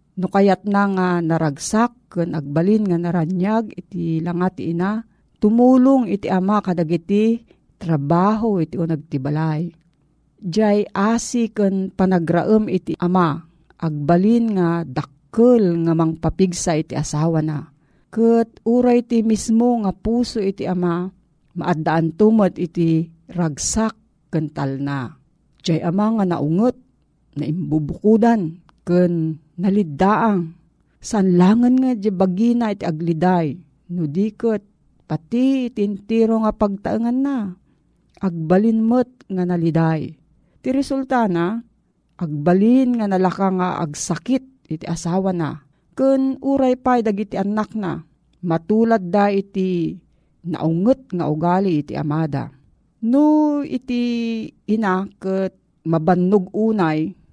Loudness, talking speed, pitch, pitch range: -19 LUFS, 110 wpm, 185 Hz, 165-220 Hz